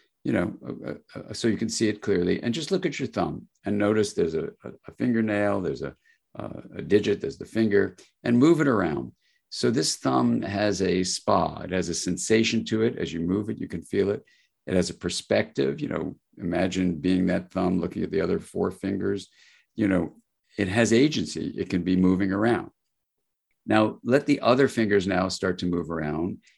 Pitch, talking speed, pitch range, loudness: 100 Hz, 210 wpm, 90-110 Hz, -25 LUFS